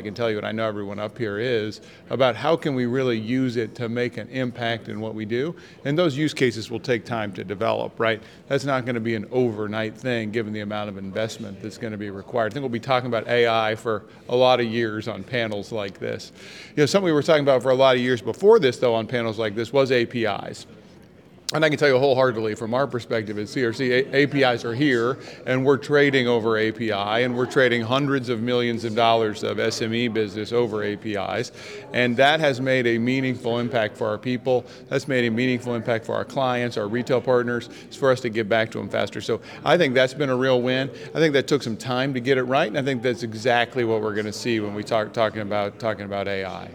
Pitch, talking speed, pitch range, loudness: 120 Hz, 245 wpm, 110-130 Hz, -23 LUFS